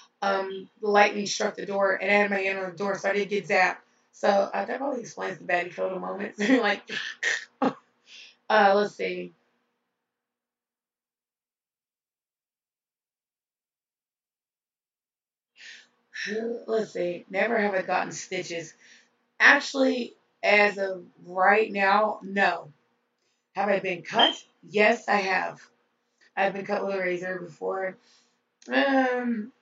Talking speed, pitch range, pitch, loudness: 120 wpm, 185-210 Hz, 200 Hz, -25 LUFS